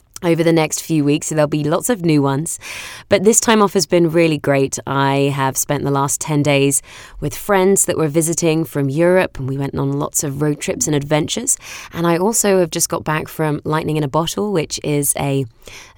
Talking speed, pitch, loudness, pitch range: 220 wpm, 155 Hz, -17 LUFS, 140-170 Hz